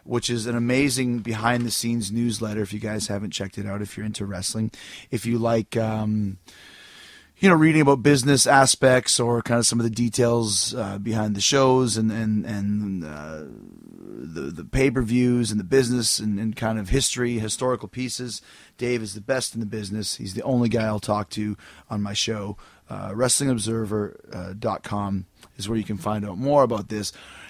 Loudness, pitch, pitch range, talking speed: -23 LUFS, 110 Hz, 105-125 Hz, 190 wpm